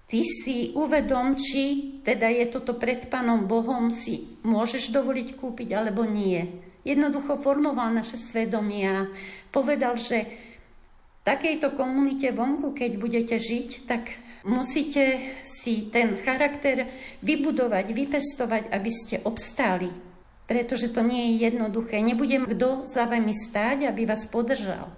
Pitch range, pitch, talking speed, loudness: 225-265 Hz, 240 Hz, 125 wpm, -26 LUFS